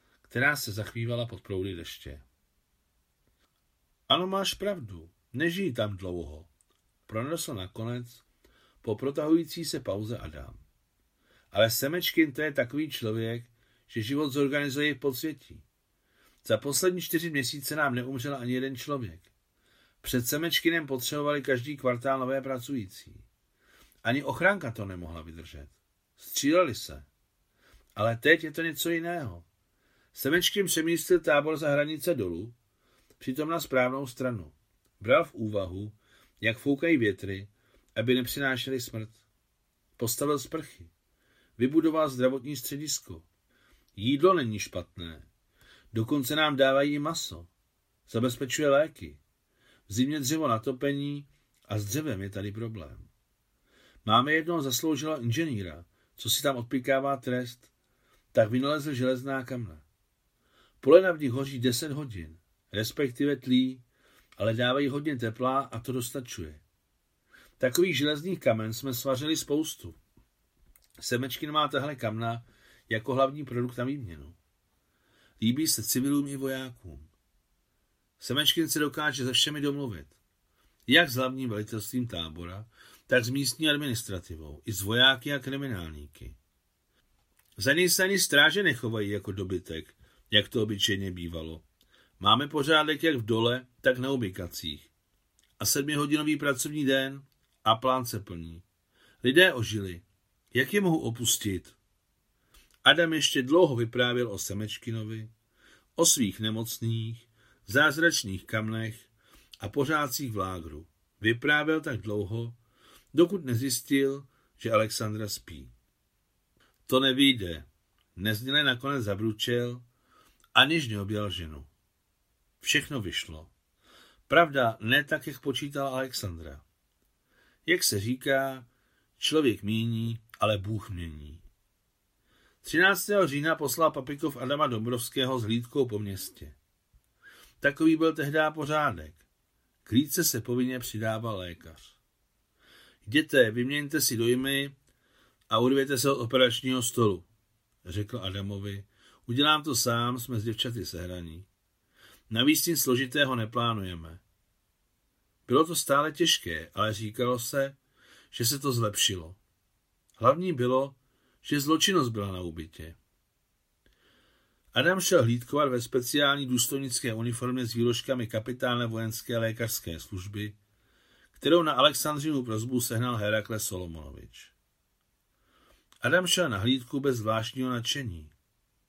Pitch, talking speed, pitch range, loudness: 120 Hz, 115 wpm, 100-140 Hz, -28 LUFS